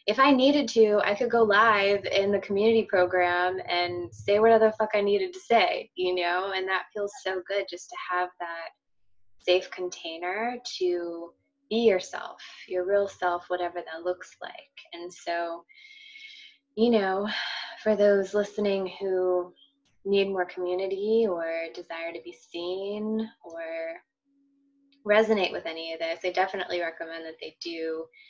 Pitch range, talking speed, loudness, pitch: 175-225 Hz, 155 wpm, -26 LUFS, 195 Hz